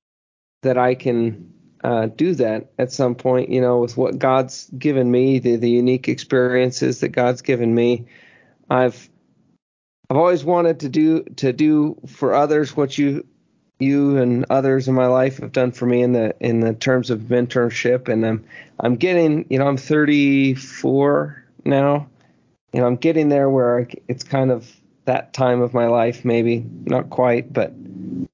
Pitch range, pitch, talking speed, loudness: 120-140 Hz, 125 Hz, 170 wpm, -19 LUFS